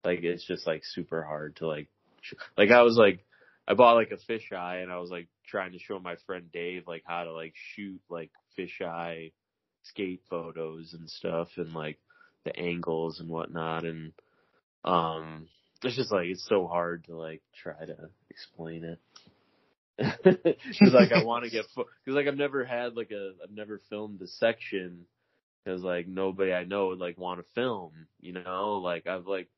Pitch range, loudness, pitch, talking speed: 85-100 Hz, -29 LUFS, 90 Hz, 190 wpm